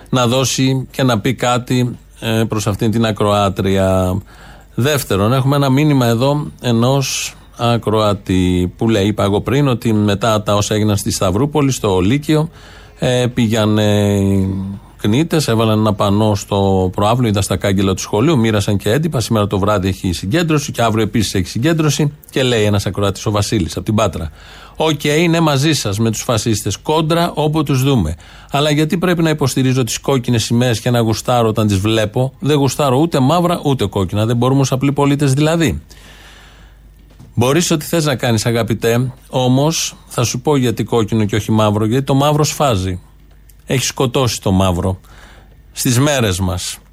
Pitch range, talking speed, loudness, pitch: 105-140 Hz, 165 wpm, -15 LUFS, 115 Hz